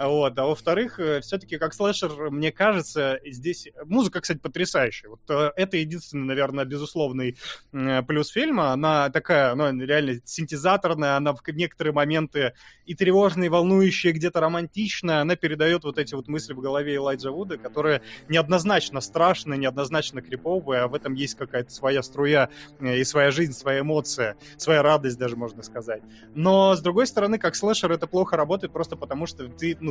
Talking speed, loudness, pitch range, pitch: 165 wpm, -24 LUFS, 135-175 Hz, 150 Hz